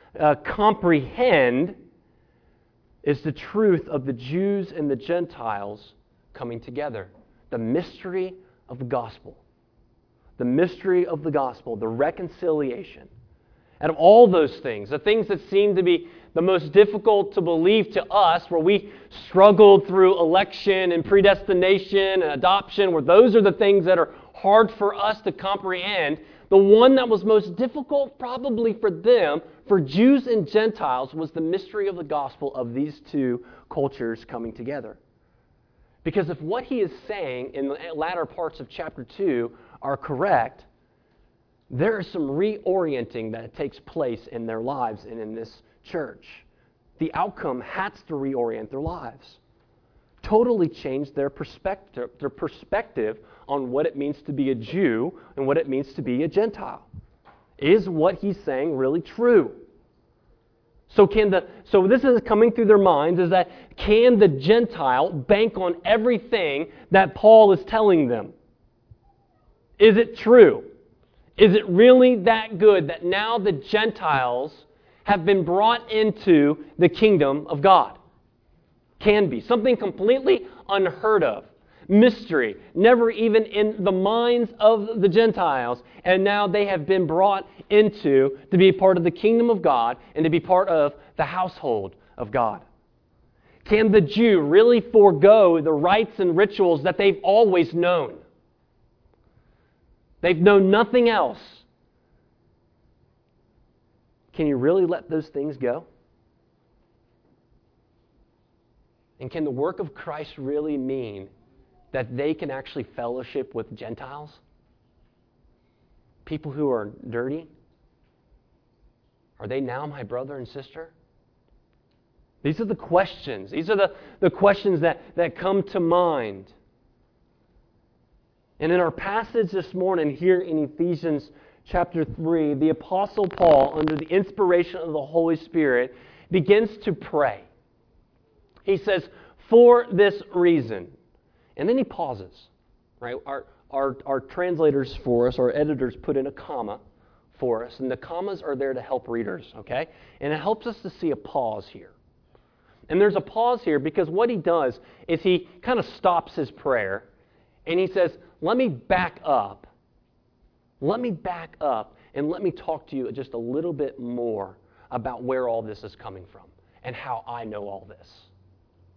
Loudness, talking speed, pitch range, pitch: -21 LUFS, 150 wpm, 135-205 Hz, 175 Hz